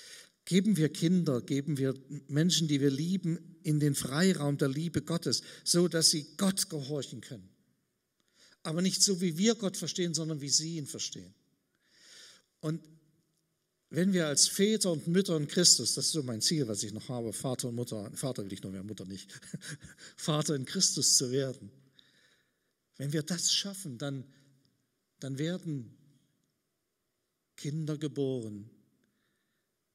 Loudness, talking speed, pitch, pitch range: -30 LUFS, 150 wpm, 150 Hz, 130-170 Hz